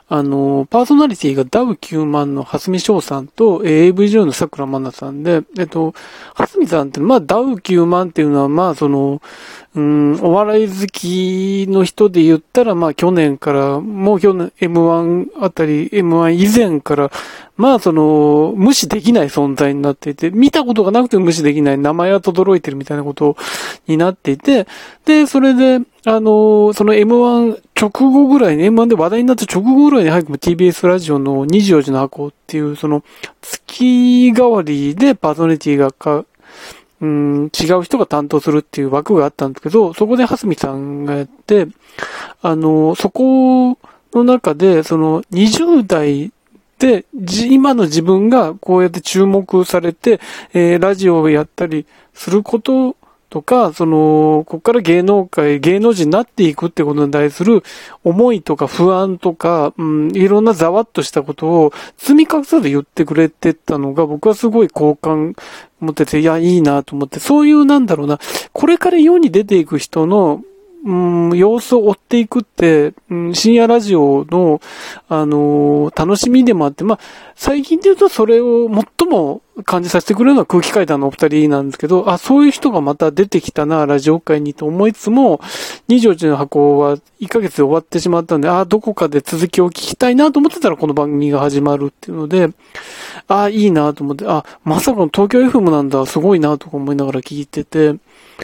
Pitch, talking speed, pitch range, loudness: 175 Hz, 340 characters per minute, 150-220 Hz, -13 LUFS